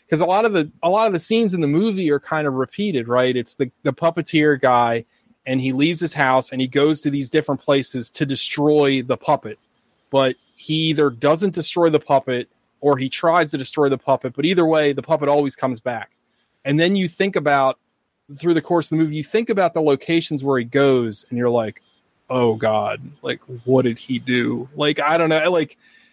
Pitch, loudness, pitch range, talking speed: 145 Hz, -19 LUFS, 130-160 Hz, 220 wpm